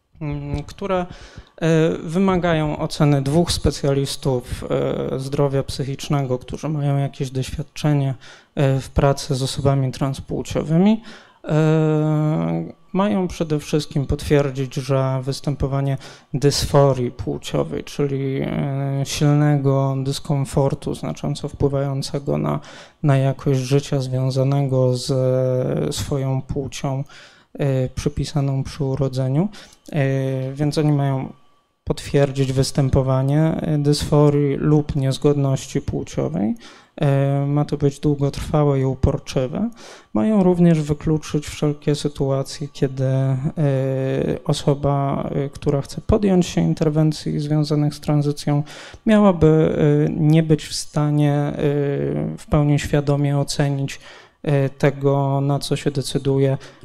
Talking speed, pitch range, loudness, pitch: 90 wpm, 135-150 Hz, -20 LUFS, 140 Hz